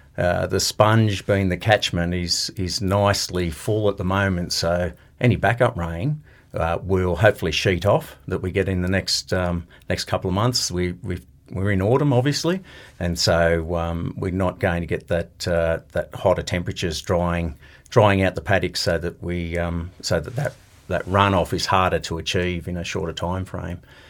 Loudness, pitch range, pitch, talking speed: -22 LUFS, 85-100 Hz, 90 Hz, 185 wpm